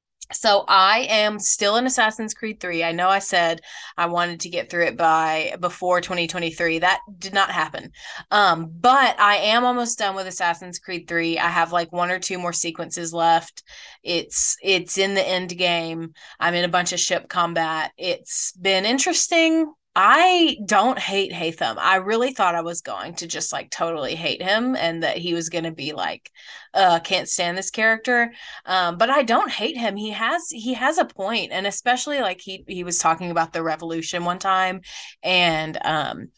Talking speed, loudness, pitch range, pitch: 190 wpm, -21 LUFS, 170-215 Hz, 185 Hz